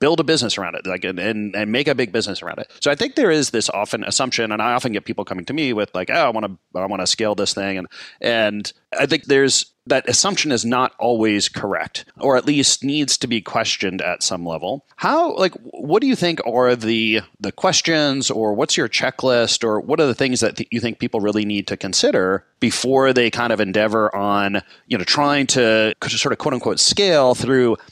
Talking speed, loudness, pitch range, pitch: 230 wpm, -18 LUFS, 105-130 Hz, 115 Hz